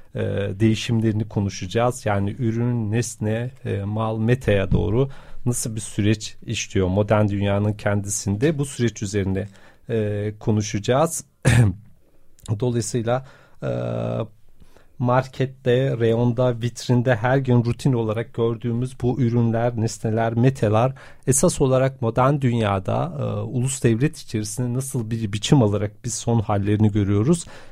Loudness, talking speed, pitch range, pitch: -22 LUFS, 100 wpm, 105-125 Hz, 115 Hz